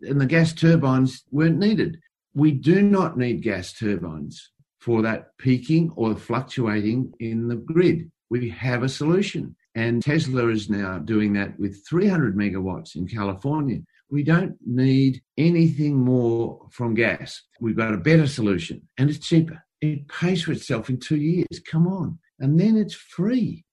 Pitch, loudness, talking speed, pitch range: 135 Hz, -22 LUFS, 160 wpm, 115-165 Hz